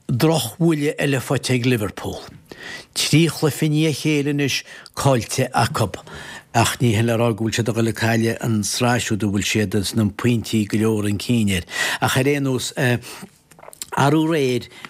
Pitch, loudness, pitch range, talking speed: 120 Hz, -20 LUFS, 110-140 Hz, 150 wpm